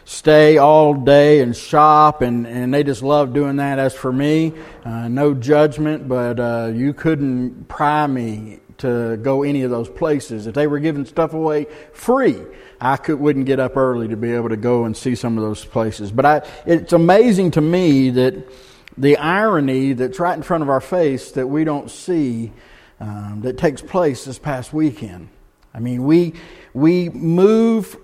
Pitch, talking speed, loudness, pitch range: 140 Hz, 195 wpm, -17 LUFS, 125-155 Hz